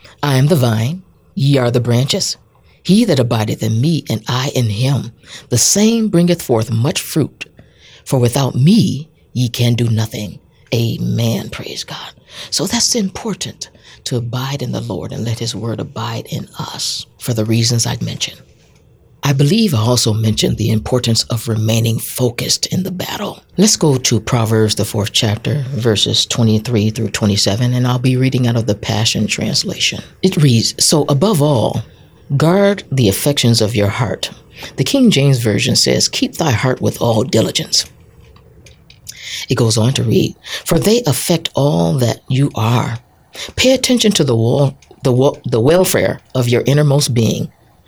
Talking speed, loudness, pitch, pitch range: 165 wpm, -15 LUFS, 125 Hz, 115-140 Hz